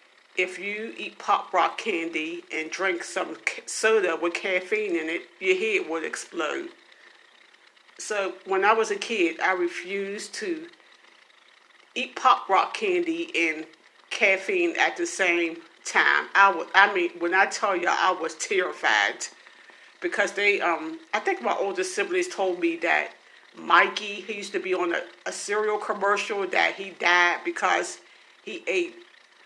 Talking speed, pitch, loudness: 155 wpm, 220 Hz, -25 LUFS